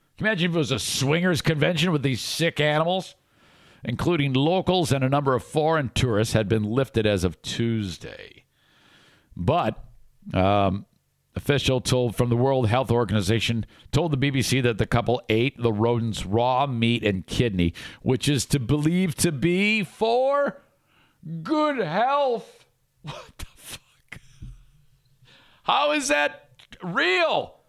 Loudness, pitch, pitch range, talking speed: -23 LUFS, 135 Hz, 115-165 Hz, 135 wpm